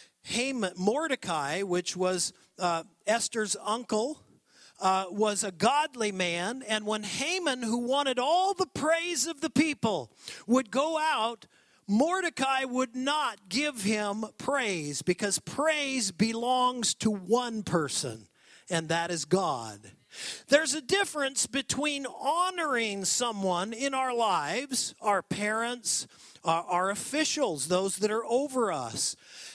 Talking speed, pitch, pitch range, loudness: 125 wpm, 230 Hz, 195-275 Hz, -29 LUFS